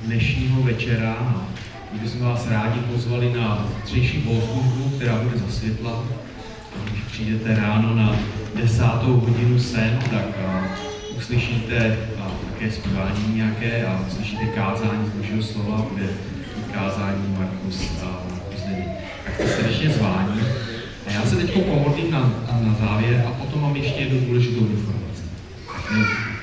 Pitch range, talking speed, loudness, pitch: 105-120 Hz, 125 wpm, -22 LUFS, 110 Hz